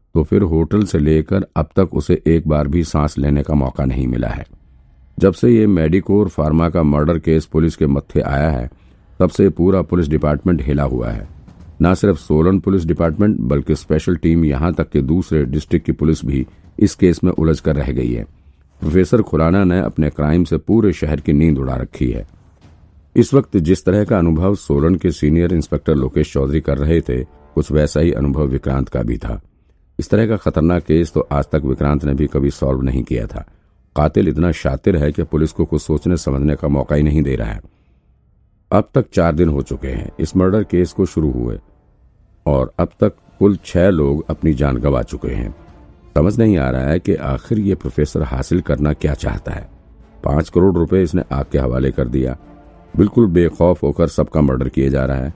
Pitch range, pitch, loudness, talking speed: 70-90 Hz, 80 Hz, -16 LUFS, 205 wpm